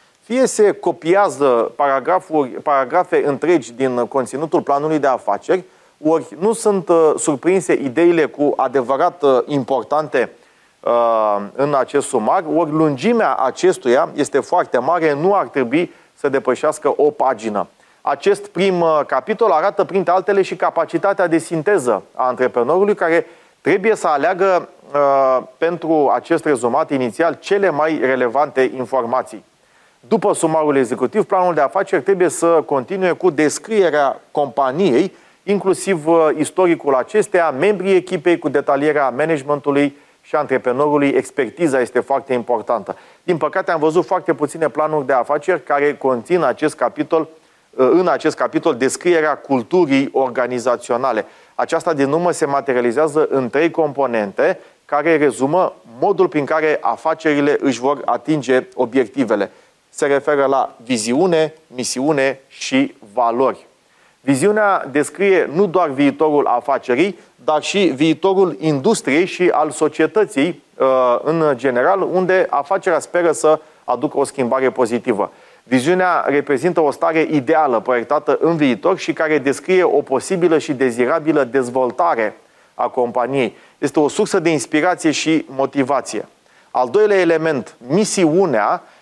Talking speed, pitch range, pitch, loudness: 125 wpm, 135-180 Hz, 155 Hz, -17 LUFS